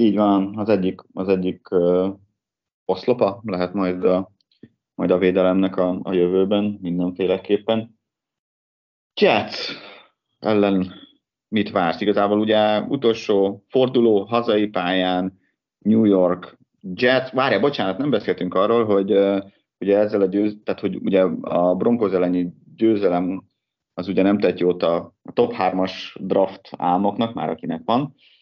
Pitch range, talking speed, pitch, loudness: 90-105 Hz, 130 wpm, 95 Hz, -20 LUFS